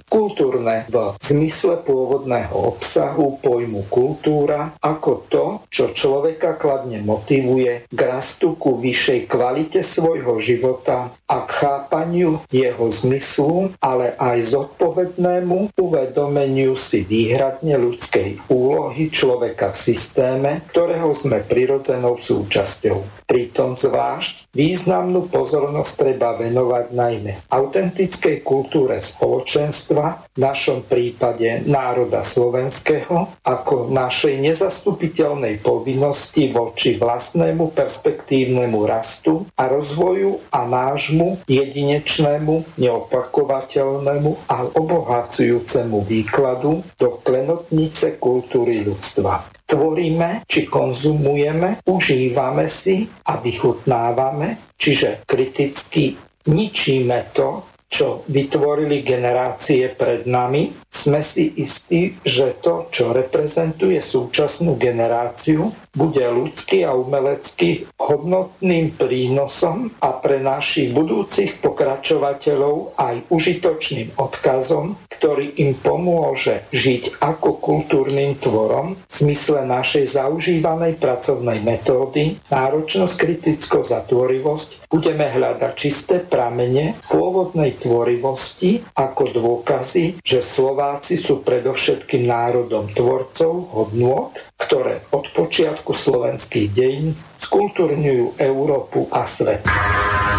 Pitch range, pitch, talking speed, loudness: 125-165 Hz, 140 Hz, 95 wpm, -18 LUFS